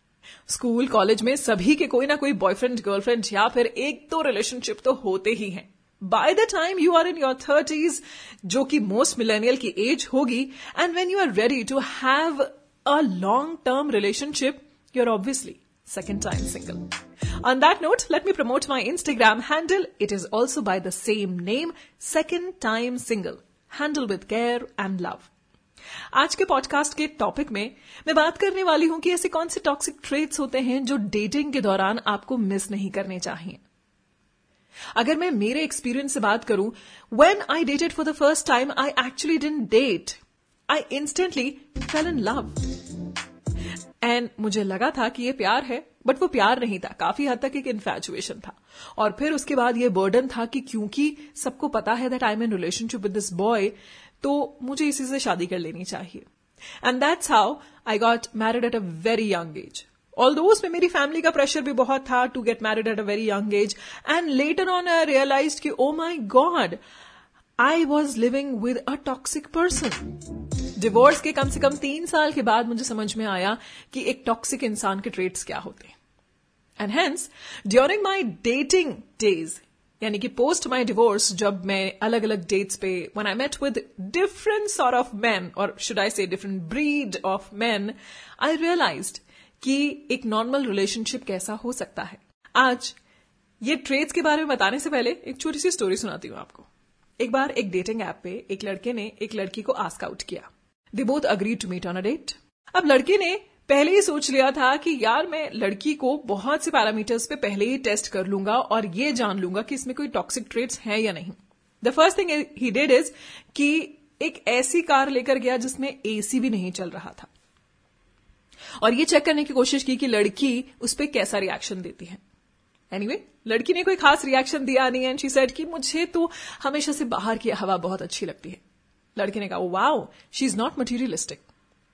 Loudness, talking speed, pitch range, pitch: -24 LUFS, 185 wpm, 215-295 Hz, 255 Hz